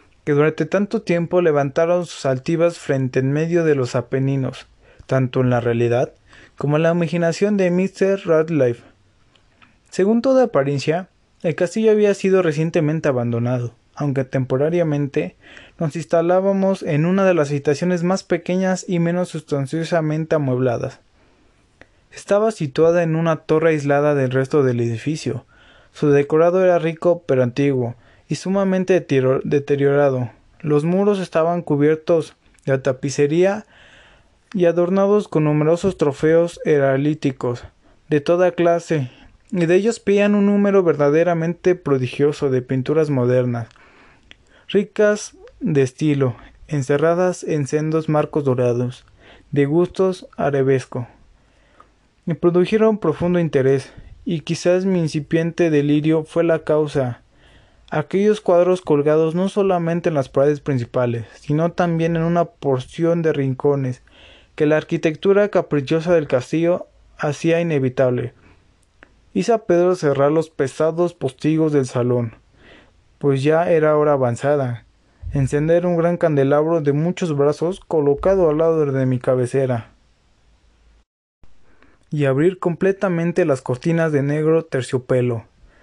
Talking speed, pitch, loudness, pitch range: 120 wpm, 155 Hz, -19 LUFS, 135-175 Hz